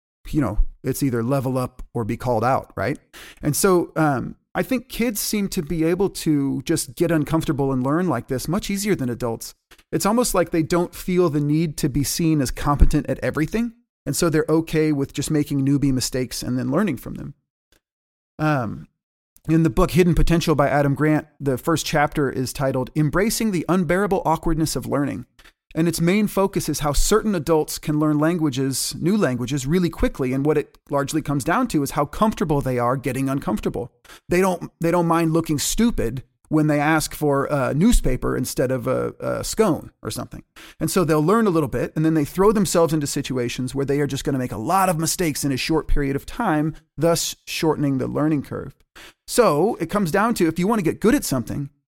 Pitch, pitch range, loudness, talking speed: 155 Hz, 135-175 Hz, -21 LUFS, 210 wpm